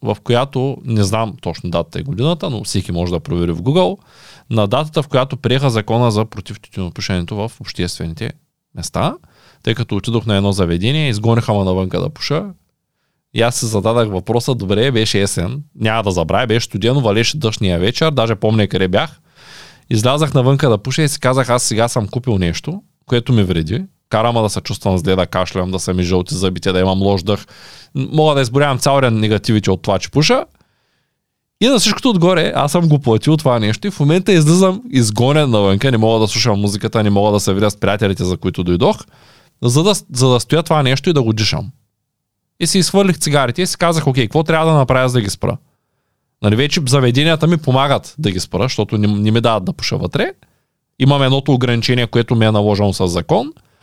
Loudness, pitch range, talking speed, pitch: -15 LUFS, 105-140 Hz, 200 wpm, 120 Hz